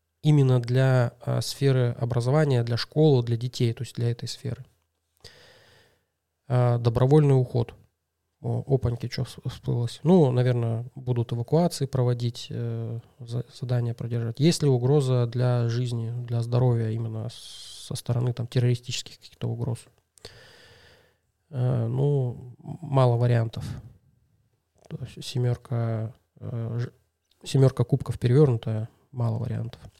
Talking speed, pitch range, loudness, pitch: 115 wpm, 115-130 Hz, -25 LUFS, 120 Hz